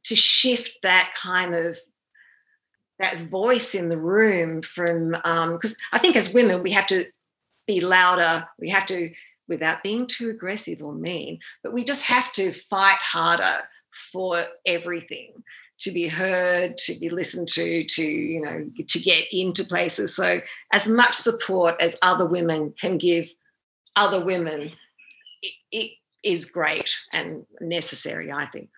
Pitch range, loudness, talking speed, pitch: 170-230 Hz, -21 LUFS, 150 wpm, 185 Hz